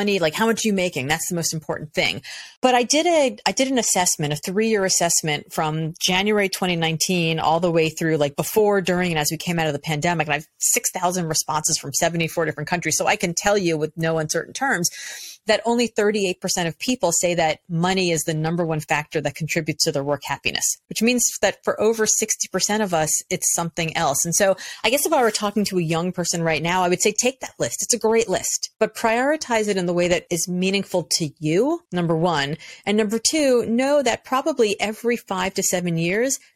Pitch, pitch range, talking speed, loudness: 180 Hz, 160-215 Hz, 225 wpm, -21 LUFS